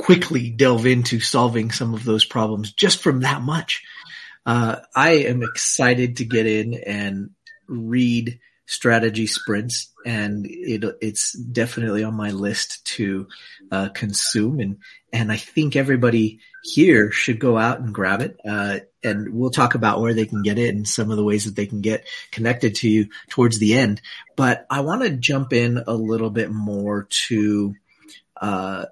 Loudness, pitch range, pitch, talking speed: -20 LUFS, 105-125 Hz, 115 Hz, 170 wpm